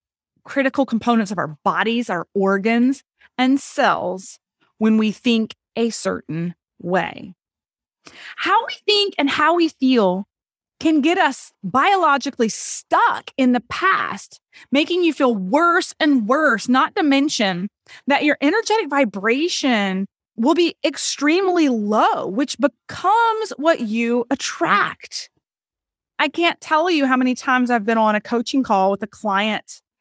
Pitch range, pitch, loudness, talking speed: 220-305 Hz, 260 Hz, -19 LUFS, 135 wpm